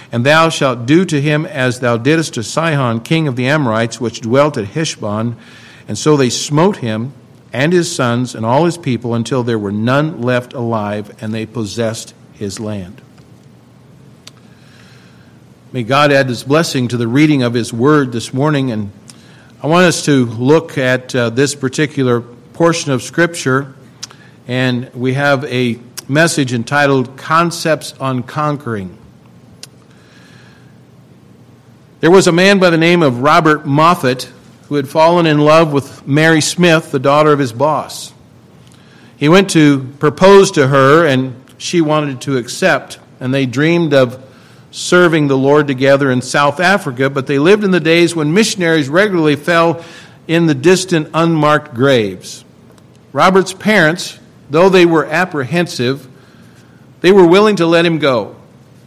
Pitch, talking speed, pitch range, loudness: 140 Hz, 150 wpm, 125-160 Hz, -12 LUFS